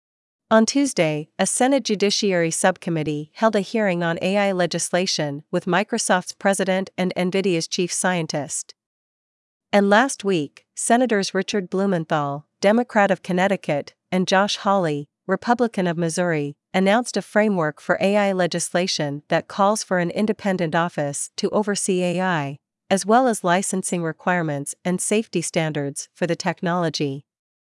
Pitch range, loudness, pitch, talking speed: 170-205 Hz, -21 LUFS, 185 Hz, 130 wpm